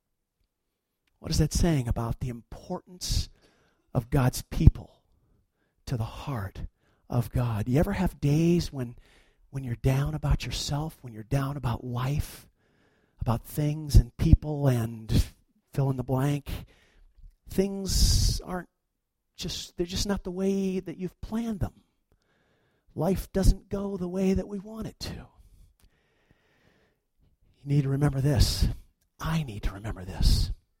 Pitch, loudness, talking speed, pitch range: 135 Hz, -29 LUFS, 140 wpm, 110-170 Hz